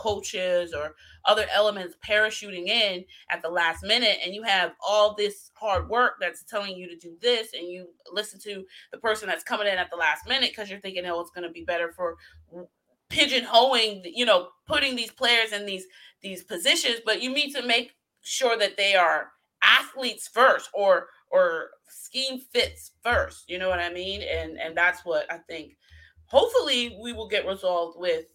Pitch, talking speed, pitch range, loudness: 205 Hz, 190 wpm, 175-240 Hz, -24 LUFS